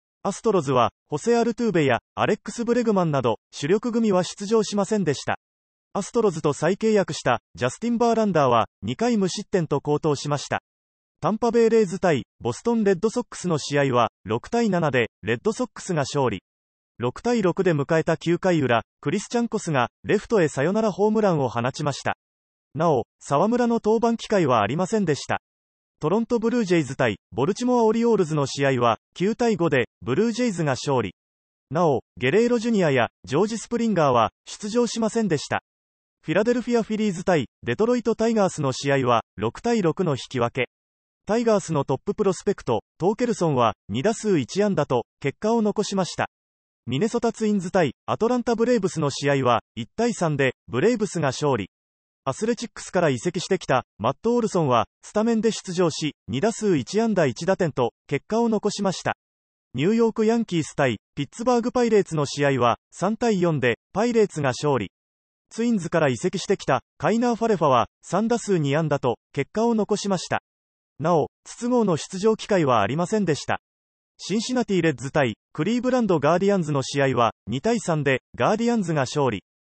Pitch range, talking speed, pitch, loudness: 130-220 Hz, 385 characters per minute, 175 Hz, -23 LUFS